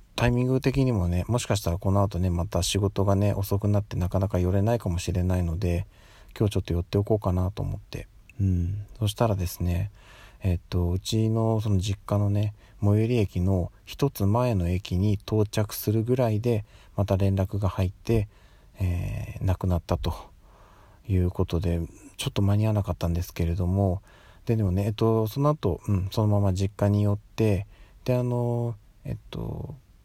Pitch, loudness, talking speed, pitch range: 100 Hz, -26 LUFS, 345 characters per minute, 95-110 Hz